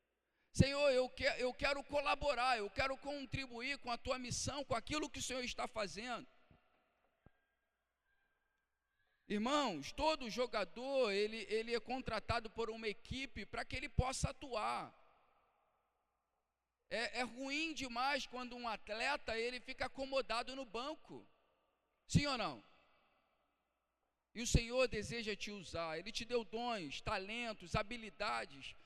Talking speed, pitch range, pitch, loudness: 125 wpm, 225-275 Hz, 245 Hz, -40 LUFS